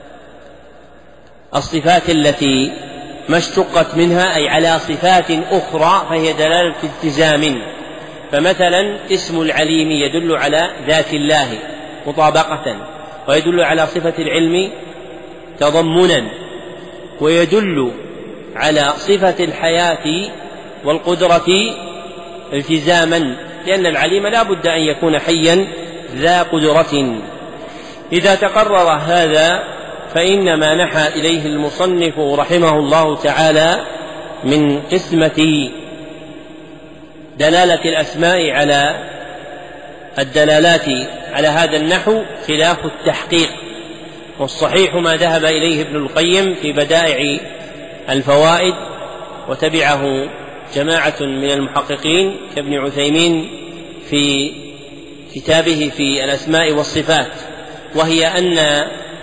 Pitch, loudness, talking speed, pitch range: 160 Hz, -14 LUFS, 85 wpm, 150-170 Hz